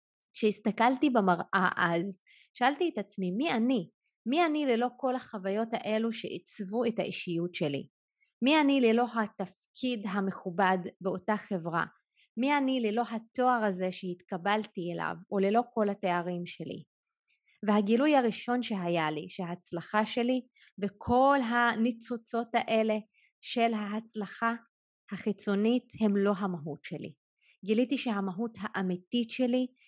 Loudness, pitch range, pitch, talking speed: -30 LUFS, 190-245 Hz, 215 Hz, 115 wpm